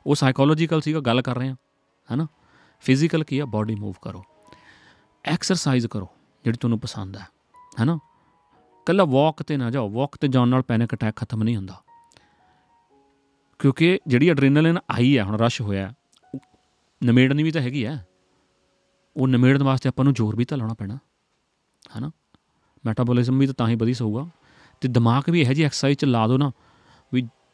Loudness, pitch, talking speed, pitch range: -22 LUFS, 130 Hz, 165 wpm, 115-145 Hz